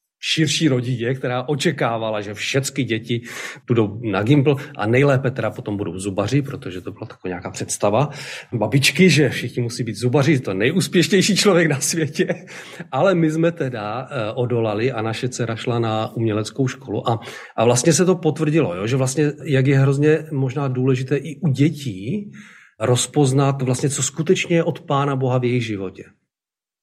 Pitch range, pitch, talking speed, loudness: 115-150 Hz, 135 Hz, 165 wpm, -20 LUFS